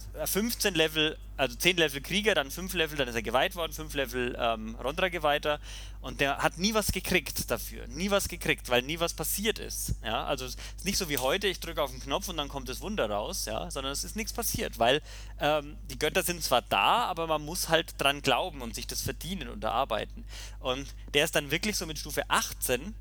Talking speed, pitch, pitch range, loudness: 225 wpm, 150 Hz, 125-170 Hz, -29 LUFS